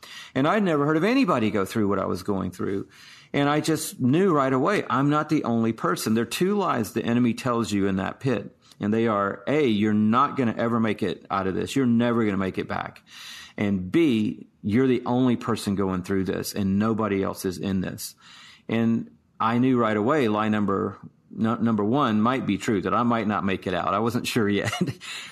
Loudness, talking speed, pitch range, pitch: -24 LUFS, 240 wpm, 100-120 Hz, 110 Hz